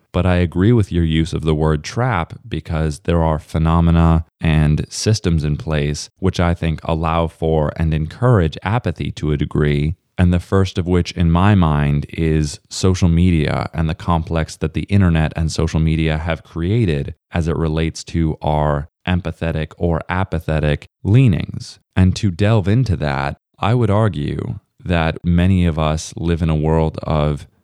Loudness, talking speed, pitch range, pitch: -18 LUFS, 165 wpm, 80-90 Hz, 80 Hz